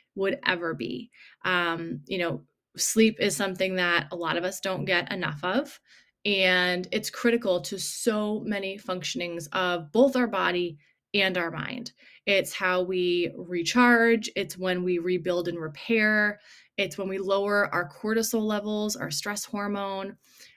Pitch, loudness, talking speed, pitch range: 190 Hz, -26 LUFS, 150 wpm, 175-210 Hz